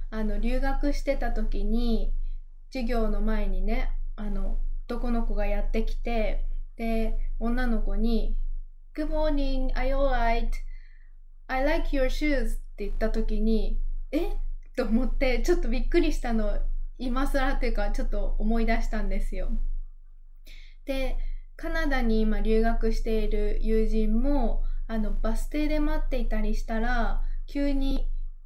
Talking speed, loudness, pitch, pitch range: 280 characters per minute, -30 LUFS, 230 Hz, 215-265 Hz